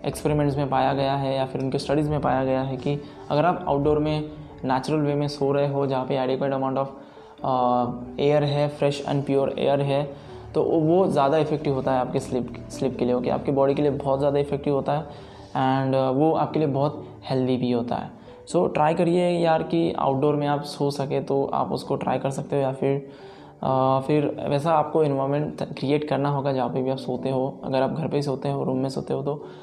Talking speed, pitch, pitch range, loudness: 225 wpm, 140 Hz, 130-145 Hz, -24 LUFS